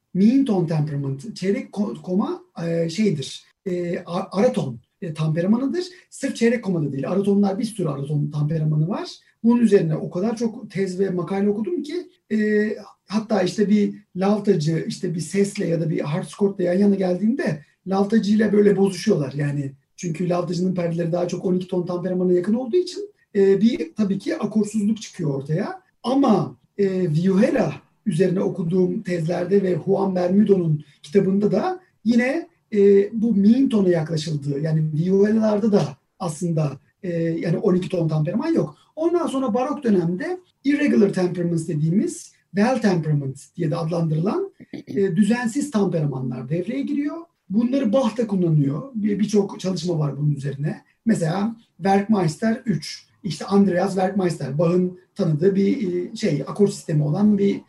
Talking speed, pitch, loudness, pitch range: 135 wpm, 195 Hz, -22 LUFS, 170-215 Hz